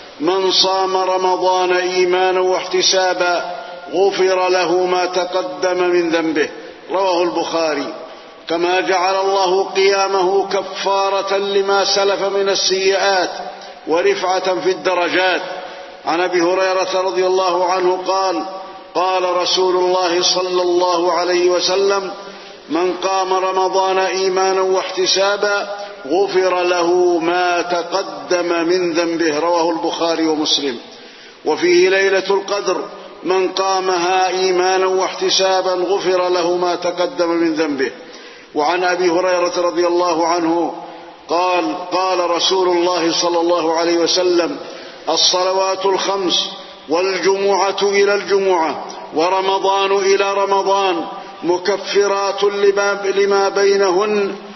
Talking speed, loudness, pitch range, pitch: 100 wpm, -16 LUFS, 175-195 Hz, 185 Hz